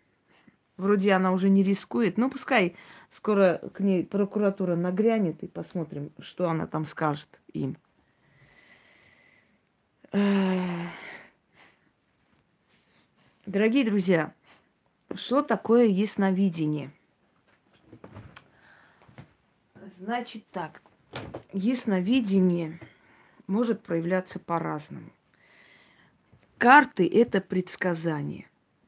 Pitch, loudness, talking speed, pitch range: 195 Hz, -26 LUFS, 70 wpm, 175-215 Hz